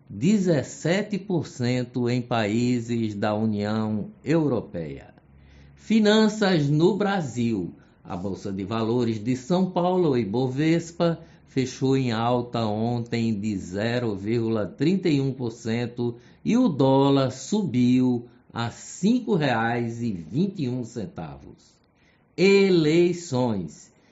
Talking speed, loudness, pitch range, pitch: 80 wpm, -24 LUFS, 115-165 Hz, 125 Hz